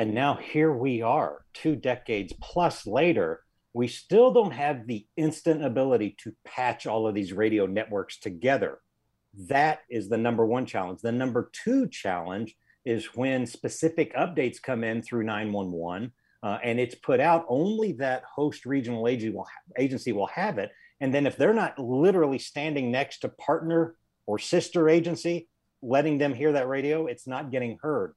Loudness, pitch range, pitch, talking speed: -27 LUFS, 115-155 Hz, 130 Hz, 170 wpm